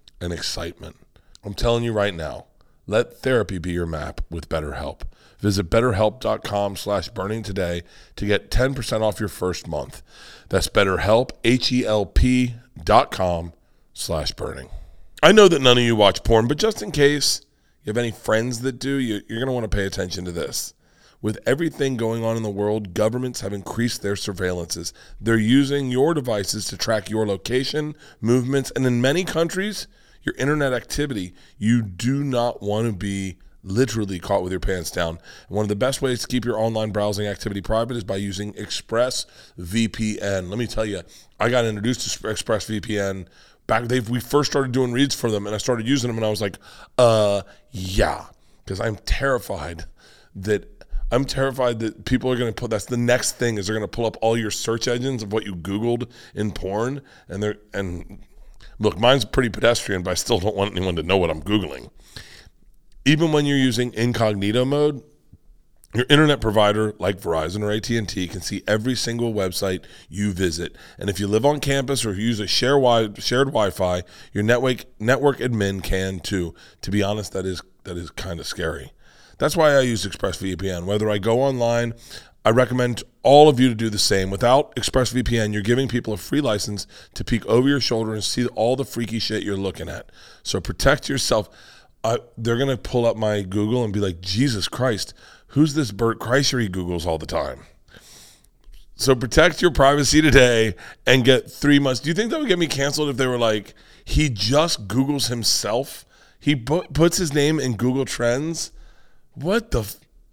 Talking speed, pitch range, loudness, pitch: 185 wpm, 100-125 Hz, -21 LUFS, 110 Hz